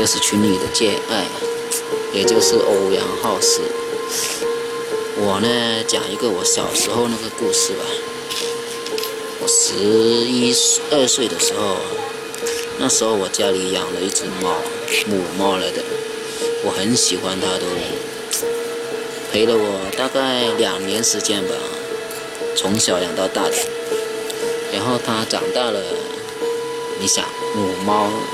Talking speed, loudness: 175 characters per minute, -19 LUFS